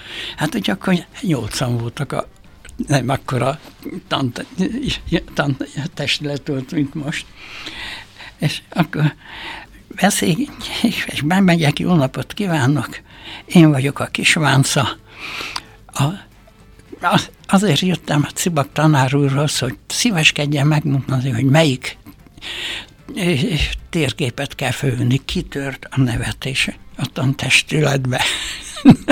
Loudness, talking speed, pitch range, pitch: -18 LUFS, 95 wpm, 130-160 Hz, 145 Hz